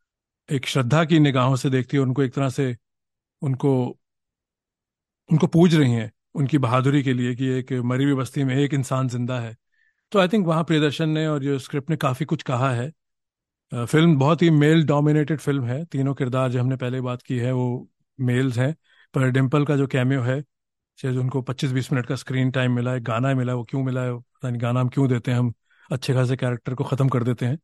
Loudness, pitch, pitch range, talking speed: -22 LUFS, 135 Hz, 125-145 Hz, 215 wpm